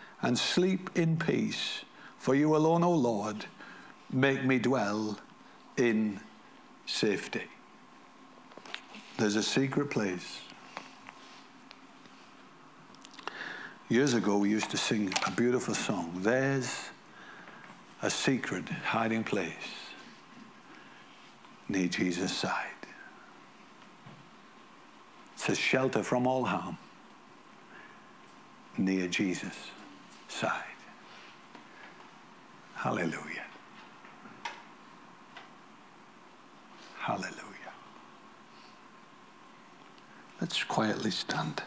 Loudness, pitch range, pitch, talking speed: -31 LUFS, 105-135 Hz, 125 Hz, 70 wpm